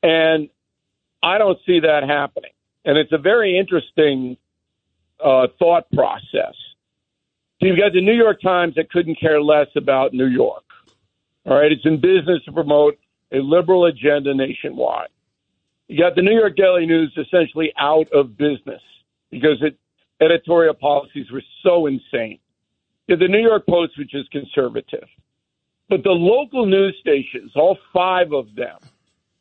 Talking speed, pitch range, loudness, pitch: 155 wpm, 140-180 Hz, -17 LUFS, 160 Hz